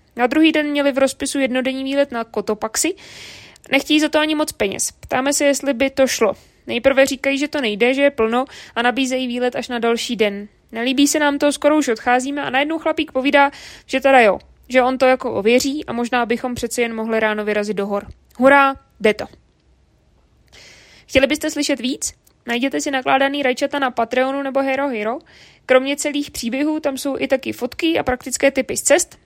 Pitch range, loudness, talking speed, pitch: 245-285 Hz, -18 LUFS, 195 wpm, 265 Hz